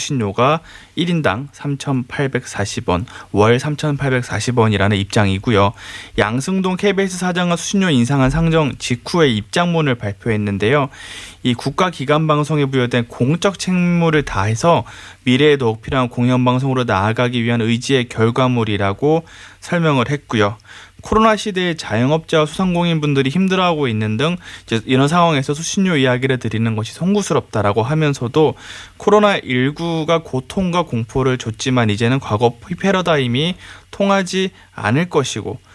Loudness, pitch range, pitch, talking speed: -17 LUFS, 115-165 Hz, 130 Hz, 340 characters per minute